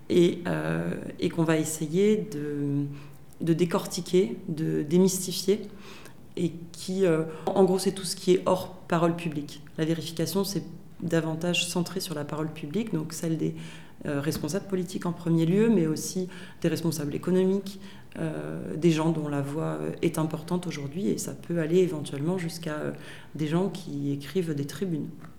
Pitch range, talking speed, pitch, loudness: 155-185 Hz, 165 wpm, 165 Hz, -28 LUFS